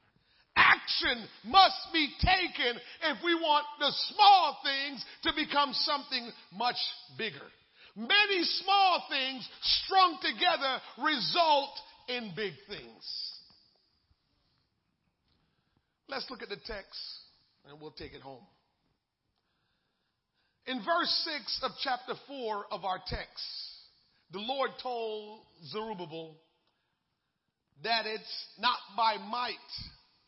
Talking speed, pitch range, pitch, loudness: 105 wpm, 215-315 Hz, 255 Hz, -29 LUFS